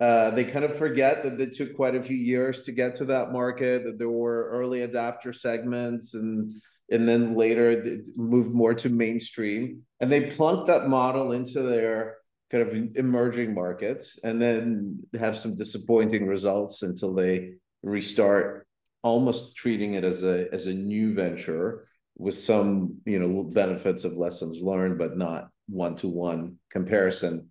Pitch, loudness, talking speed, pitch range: 115 Hz, -26 LUFS, 160 wpm, 100-125 Hz